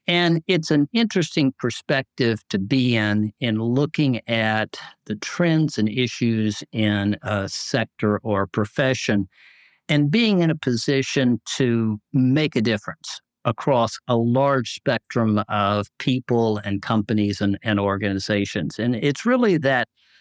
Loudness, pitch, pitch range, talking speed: -22 LUFS, 115 Hz, 105-140 Hz, 135 wpm